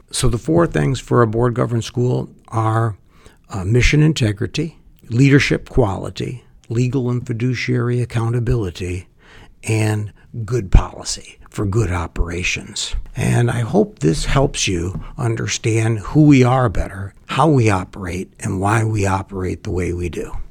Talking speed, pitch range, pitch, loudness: 140 wpm, 95-125 Hz, 115 Hz, -18 LUFS